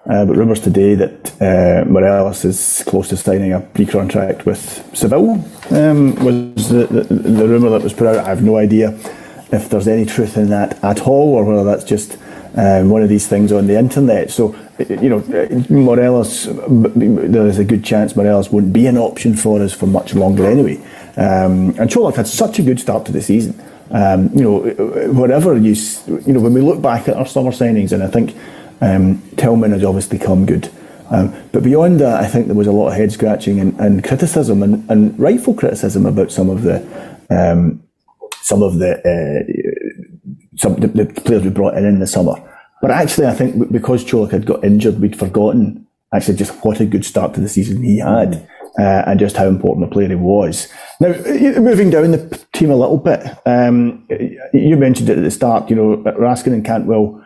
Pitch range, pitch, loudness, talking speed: 100-125 Hz, 110 Hz, -13 LUFS, 205 wpm